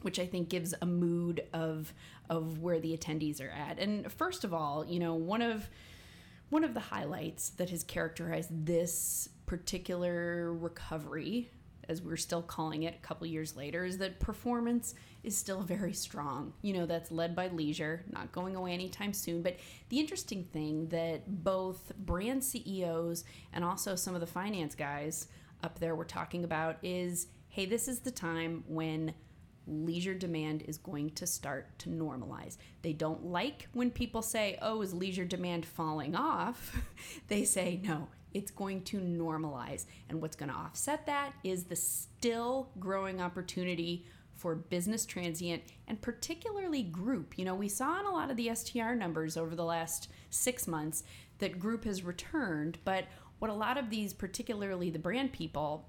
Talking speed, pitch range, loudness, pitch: 170 wpm, 160-200 Hz, -37 LUFS, 175 Hz